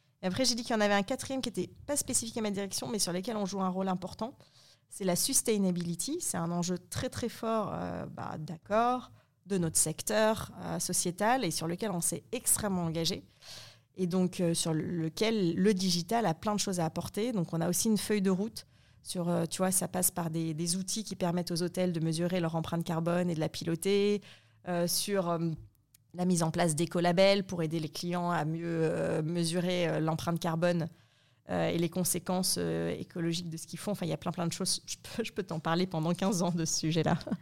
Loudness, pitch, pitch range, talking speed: -31 LUFS, 175 Hz, 165-200 Hz, 220 wpm